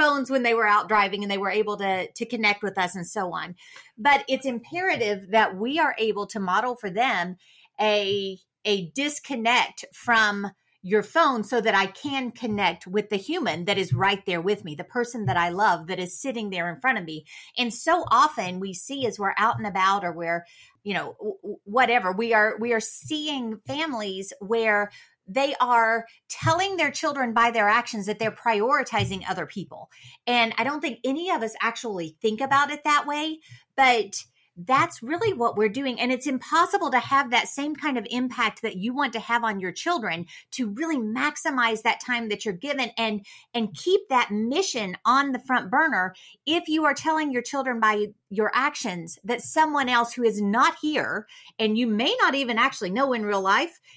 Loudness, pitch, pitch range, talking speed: -24 LUFS, 230 Hz, 200-275 Hz, 195 wpm